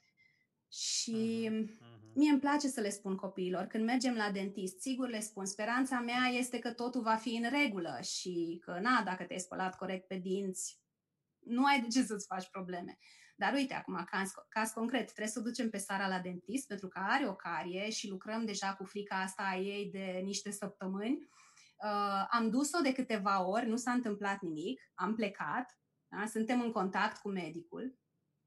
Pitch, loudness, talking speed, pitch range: 205 Hz, -36 LUFS, 185 wpm, 190-240 Hz